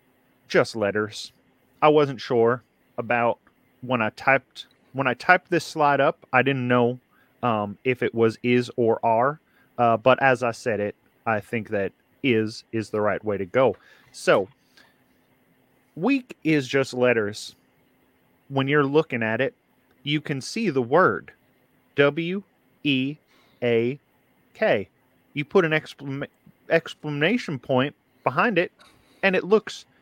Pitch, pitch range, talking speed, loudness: 130 Hz, 115-145 Hz, 140 wpm, -23 LUFS